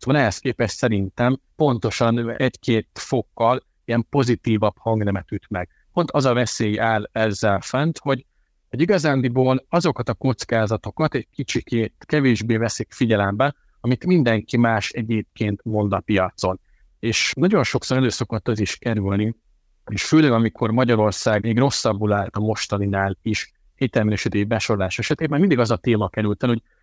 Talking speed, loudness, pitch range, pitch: 145 wpm, -21 LUFS, 105-130 Hz, 115 Hz